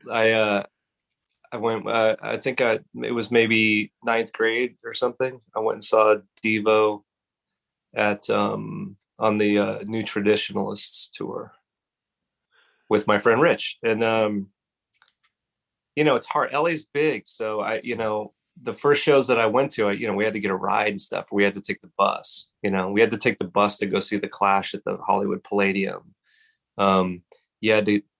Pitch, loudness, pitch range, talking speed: 110 Hz, -23 LUFS, 100-115 Hz, 190 wpm